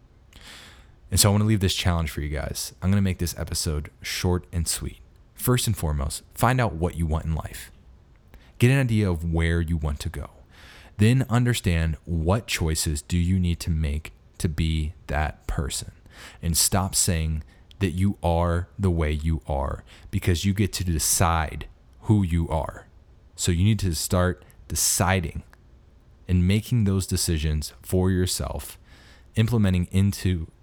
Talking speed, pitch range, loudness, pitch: 165 wpm, 80-95 Hz, -24 LUFS, 85 Hz